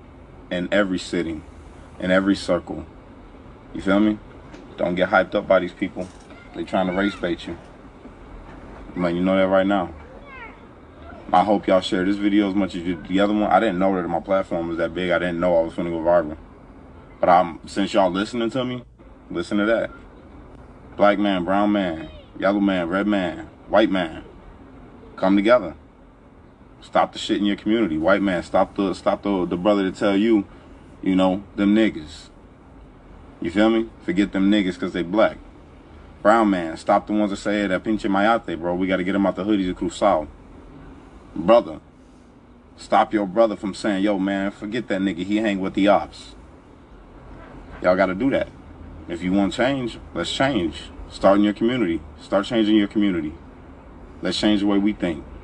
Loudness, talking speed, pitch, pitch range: -21 LUFS, 190 wpm, 95 Hz, 90-105 Hz